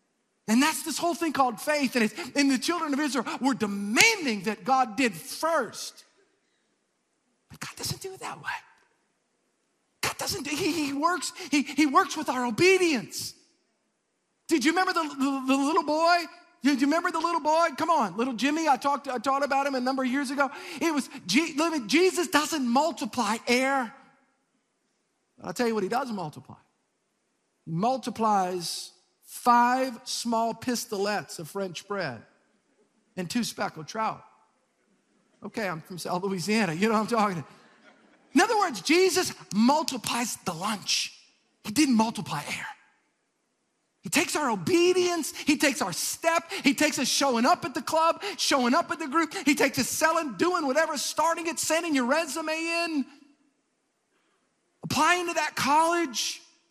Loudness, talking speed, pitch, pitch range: -26 LUFS, 160 wpm, 280 Hz, 240-325 Hz